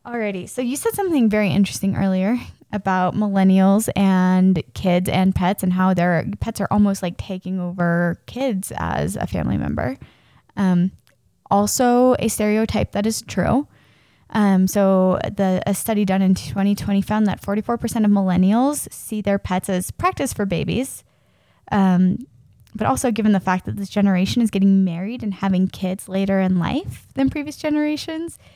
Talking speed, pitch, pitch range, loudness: 160 wpm, 195 Hz, 185-225 Hz, -20 LUFS